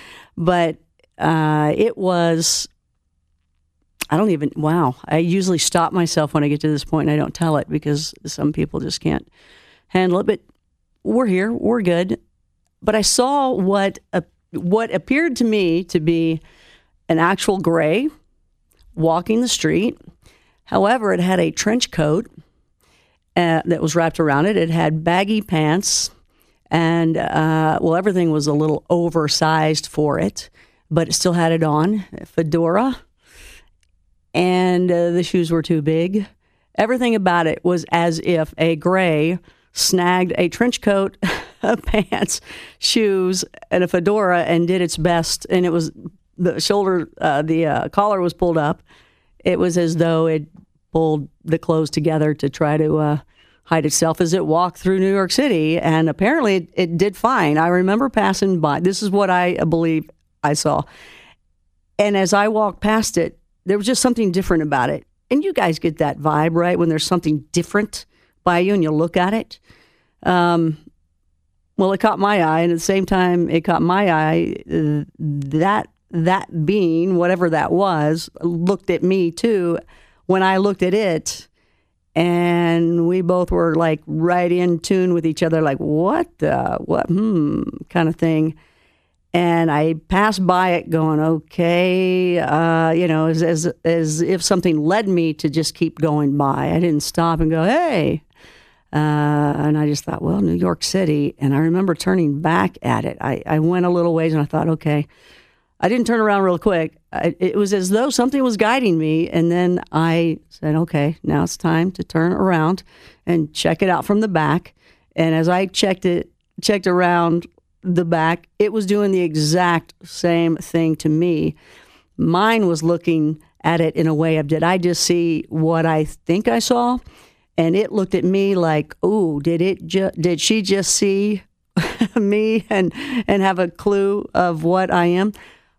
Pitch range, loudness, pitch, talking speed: 160-190 Hz, -18 LUFS, 170 Hz, 175 wpm